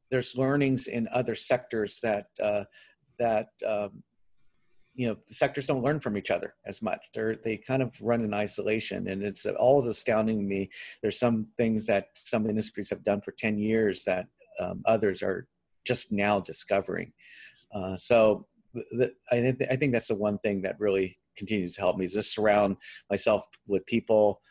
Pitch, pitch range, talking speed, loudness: 110 Hz, 100-115 Hz, 195 wpm, -29 LUFS